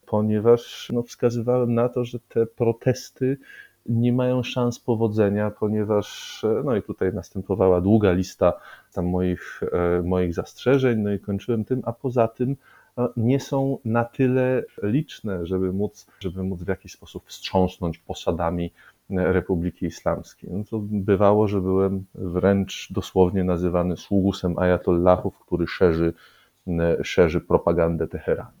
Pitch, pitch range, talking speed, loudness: 100 Hz, 90-120 Hz, 130 wpm, -23 LUFS